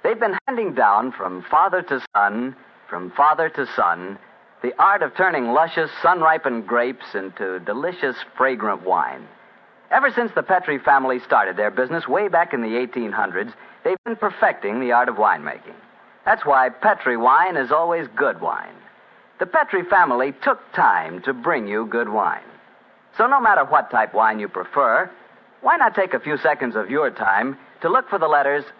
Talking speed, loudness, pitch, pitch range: 175 wpm, -20 LUFS, 135 Hz, 120-165 Hz